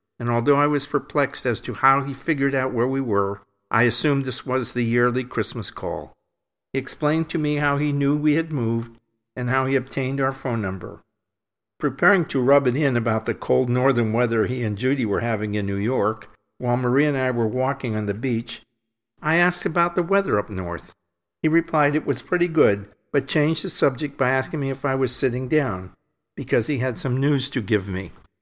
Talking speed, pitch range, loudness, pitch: 210 wpm, 115-145 Hz, -22 LUFS, 130 Hz